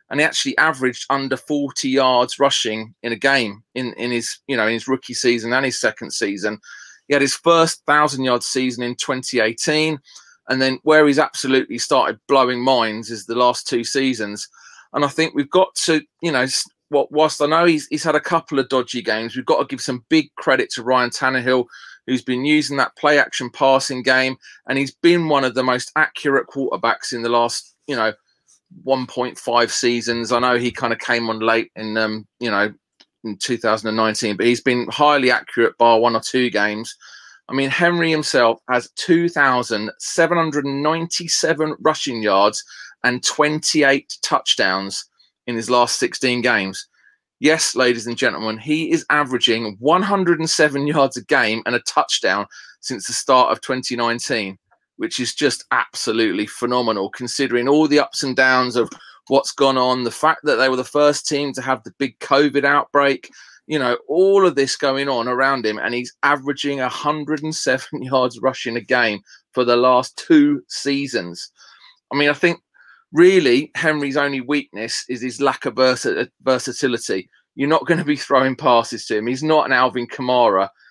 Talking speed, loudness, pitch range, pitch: 175 wpm, -18 LUFS, 120-150 Hz, 130 Hz